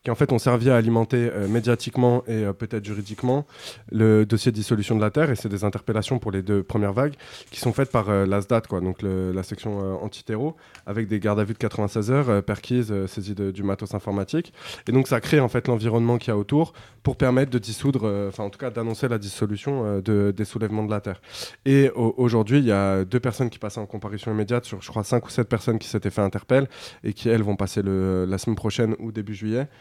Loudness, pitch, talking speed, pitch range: -24 LUFS, 110 Hz, 250 wpm, 105-125 Hz